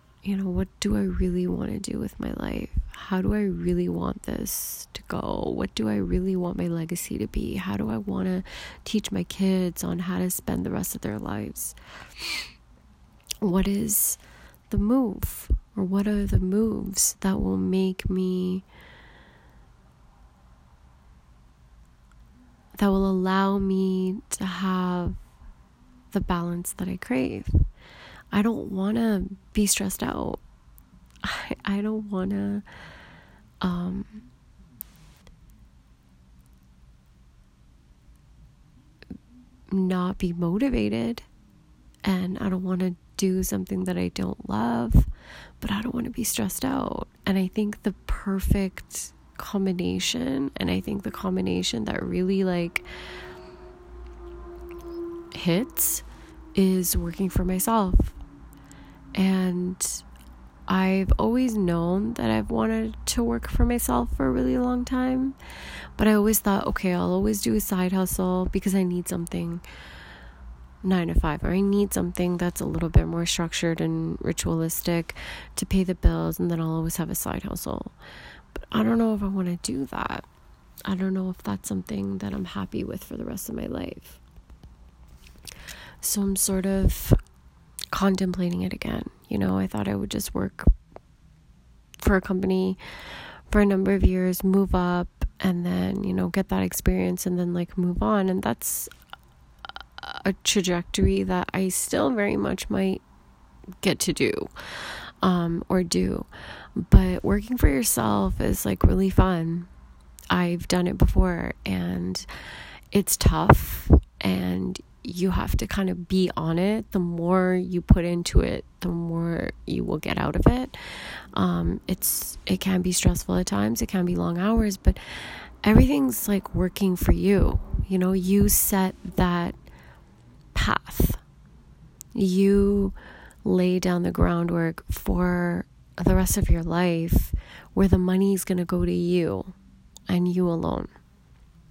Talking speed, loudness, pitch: 145 wpm, -25 LUFS, 175 Hz